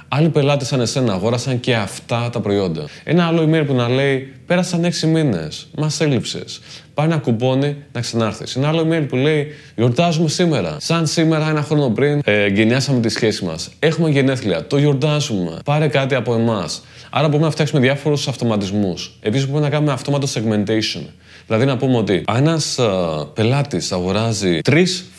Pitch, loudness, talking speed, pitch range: 135 Hz, -18 LUFS, 165 wpm, 115-150 Hz